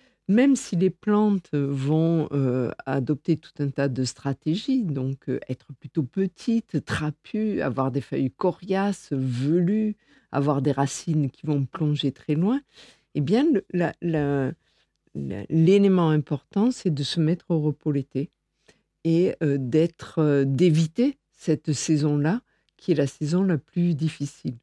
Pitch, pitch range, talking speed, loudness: 155 Hz, 140-185 Hz, 150 wpm, -24 LUFS